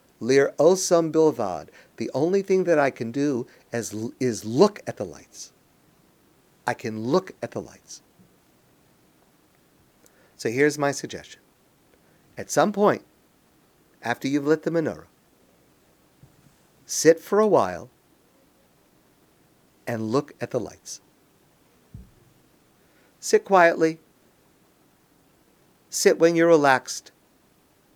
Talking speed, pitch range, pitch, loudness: 105 wpm, 125-165 Hz, 145 Hz, -23 LUFS